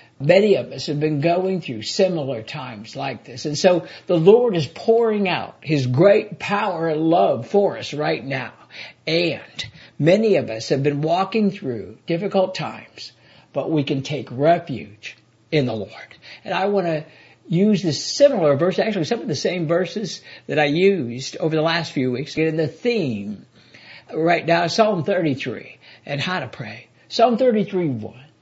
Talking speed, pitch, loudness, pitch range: 175 wpm, 160 Hz, -20 LUFS, 135-185 Hz